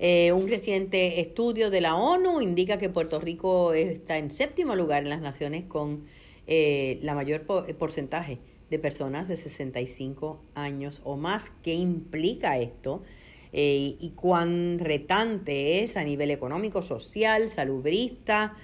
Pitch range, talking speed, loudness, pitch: 145-190 Hz, 140 wpm, -28 LUFS, 165 Hz